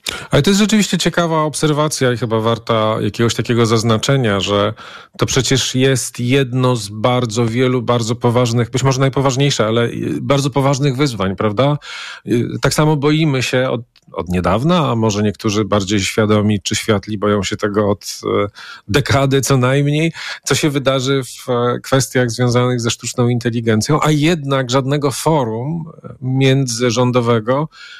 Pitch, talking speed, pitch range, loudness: 125 Hz, 140 wpm, 115-140 Hz, -16 LUFS